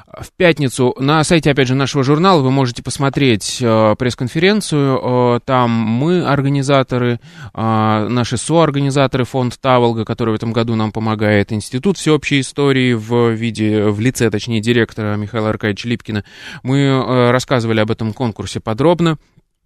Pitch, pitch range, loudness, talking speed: 125 Hz, 110-140 Hz, -15 LUFS, 130 wpm